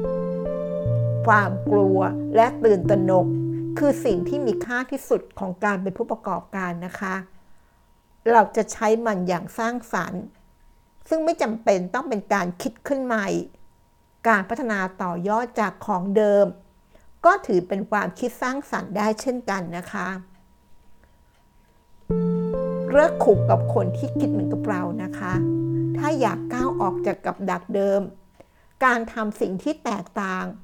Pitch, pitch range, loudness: 195 Hz, 145-225 Hz, -23 LUFS